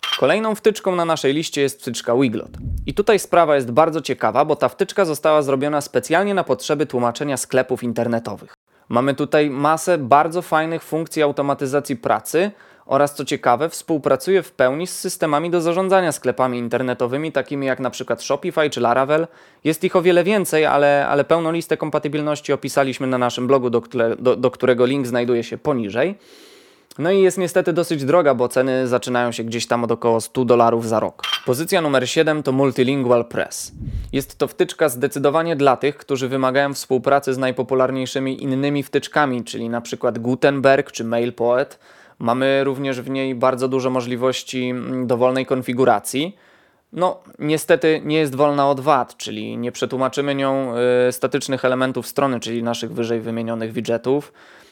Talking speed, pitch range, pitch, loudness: 160 wpm, 125-155 Hz, 135 Hz, -19 LUFS